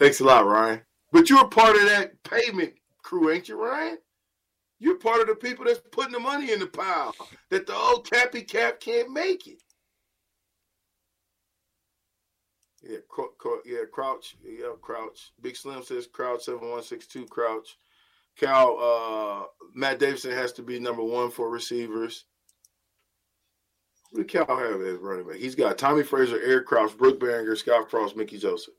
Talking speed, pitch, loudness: 165 wpm, 145 Hz, -24 LUFS